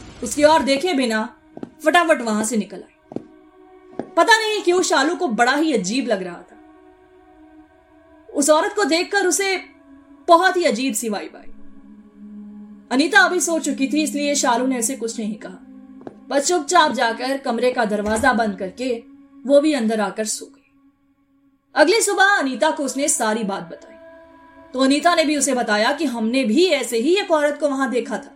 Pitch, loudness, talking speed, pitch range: 285 Hz, -18 LUFS, 170 wpm, 240-330 Hz